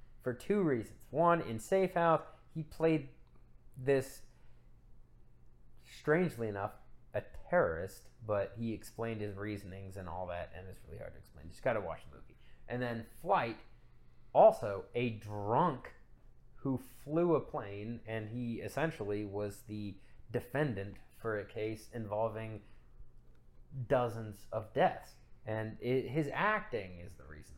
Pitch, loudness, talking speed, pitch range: 115 Hz, -36 LUFS, 135 wpm, 105-130 Hz